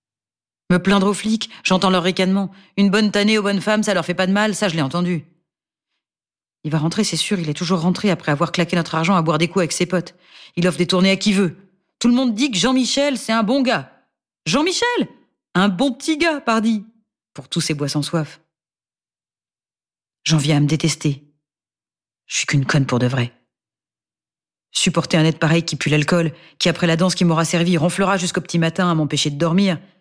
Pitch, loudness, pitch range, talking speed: 180 Hz, -18 LUFS, 160-200 Hz, 215 wpm